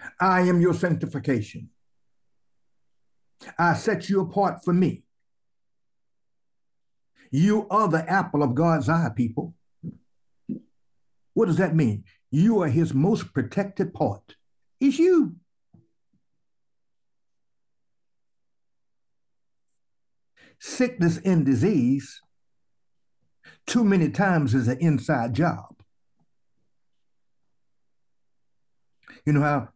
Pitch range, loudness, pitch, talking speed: 130-190 Hz, -23 LUFS, 160 Hz, 85 wpm